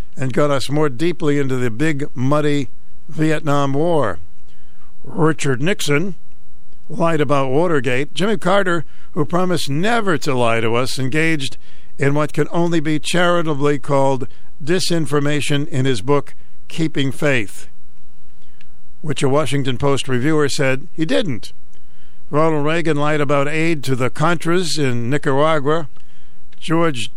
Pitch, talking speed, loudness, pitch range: 145 Hz, 130 wpm, -19 LUFS, 130-160 Hz